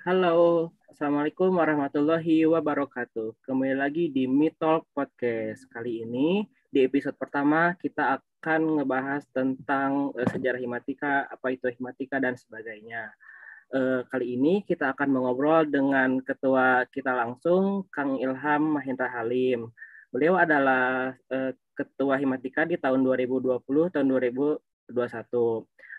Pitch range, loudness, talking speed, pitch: 130-150 Hz, -26 LUFS, 120 wpm, 135 Hz